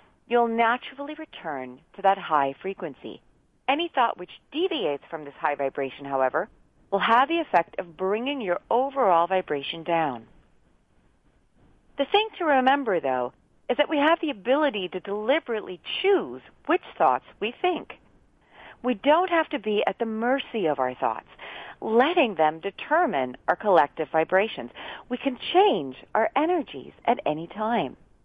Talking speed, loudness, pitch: 145 wpm, -25 LUFS, 220 Hz